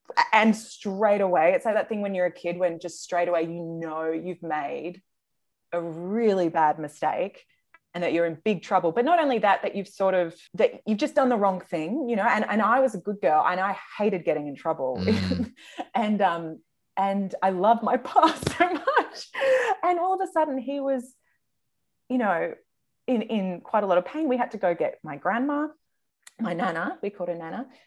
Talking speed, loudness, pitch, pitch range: 210 wpm, -25 LUFS, 205 Hz, 175-265 Hz